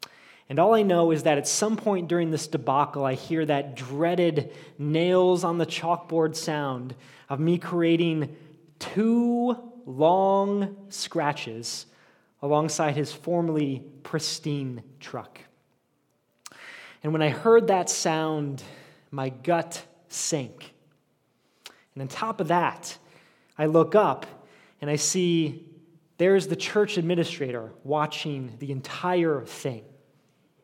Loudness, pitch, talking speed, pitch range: -25 LUFS, 160 Hz, 120 wpm, 145-175 Hz